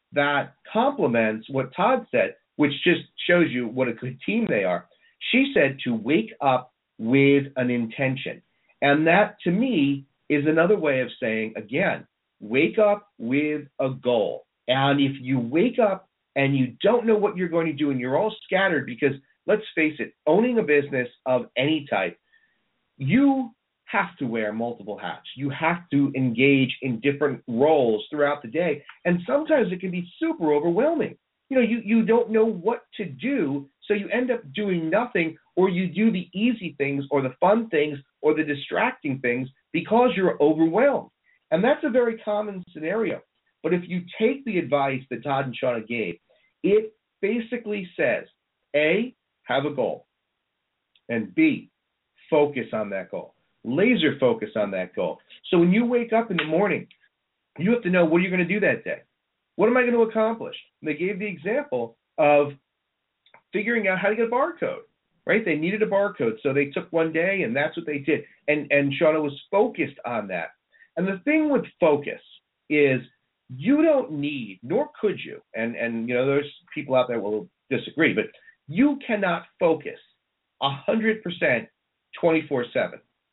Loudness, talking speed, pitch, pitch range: -24 LUFS, 175 wpm, 165 Hz, 140-215 Hz